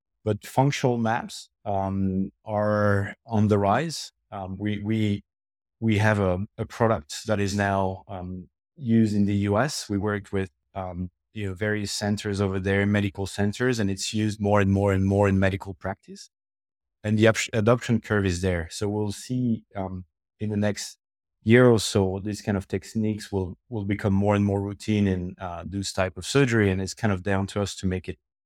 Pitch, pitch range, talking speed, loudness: 100 Hz, 95-105 Hz, 190 wpm, -25 LUFS